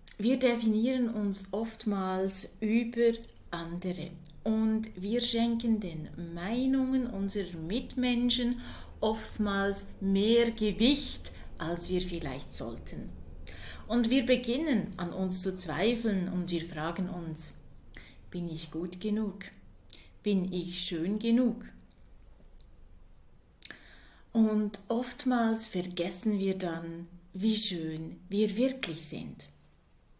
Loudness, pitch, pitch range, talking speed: -32 LUFS, 200 Hz, 175-230 Hz, 95 wpm